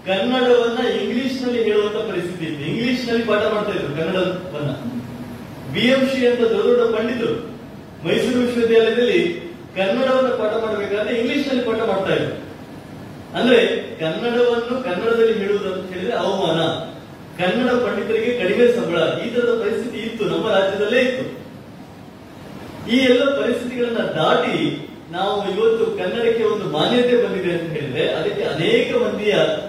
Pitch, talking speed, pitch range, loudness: 225 Hz, 110 wpm, 185-245 Hz, -19 LUFS